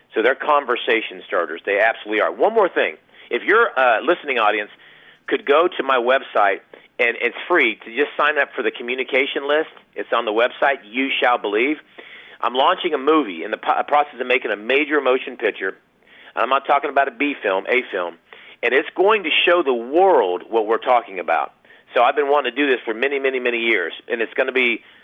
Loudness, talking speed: -19 LUFS, 210 wpm